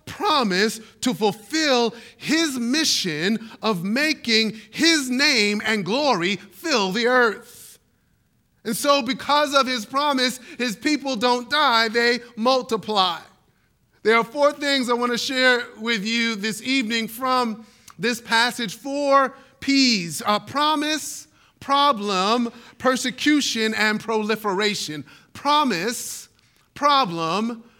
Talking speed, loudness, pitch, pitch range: 110 wpm, -21 LUFS, 240 Hz, 220-275 Hz